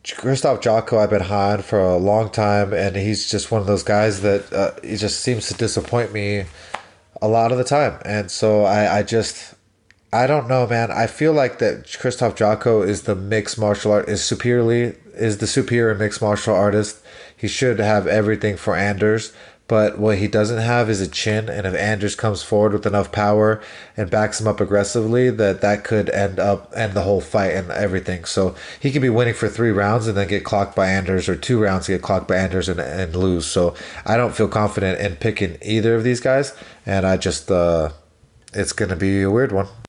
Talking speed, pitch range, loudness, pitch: 210 wpm, 100-115 Hz, -19 LUFS, 105 Hz